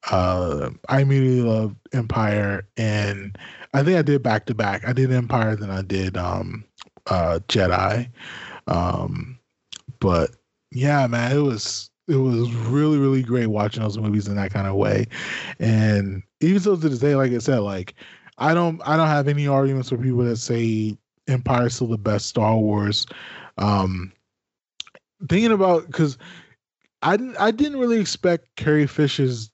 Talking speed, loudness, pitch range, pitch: 165 wpm, -21 LUFS, 105-145 Hz, 120 Hz